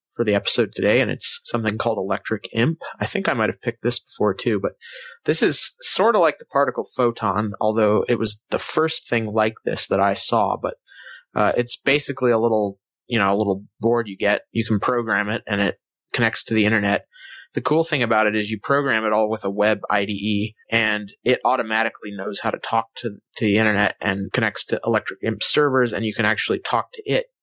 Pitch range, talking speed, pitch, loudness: 105-120 Hz, 220 wpm, 110 Hz, -21 LUFS